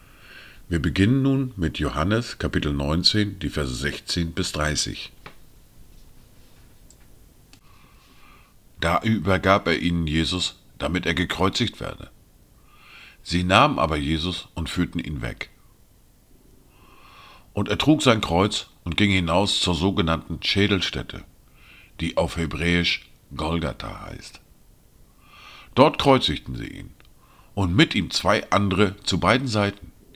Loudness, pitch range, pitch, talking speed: -22 LUFS, 80-100 Hz, 90 Hz, 115 wpm